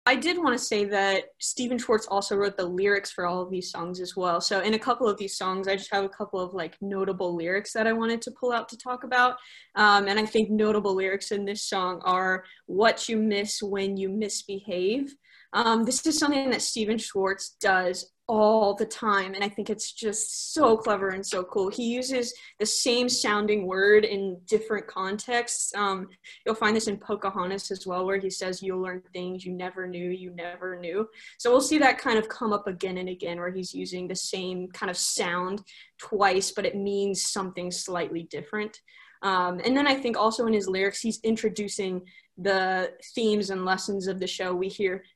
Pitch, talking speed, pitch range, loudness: 200 Hz, 205 wpm, 185-220 Hz, -27 LUFS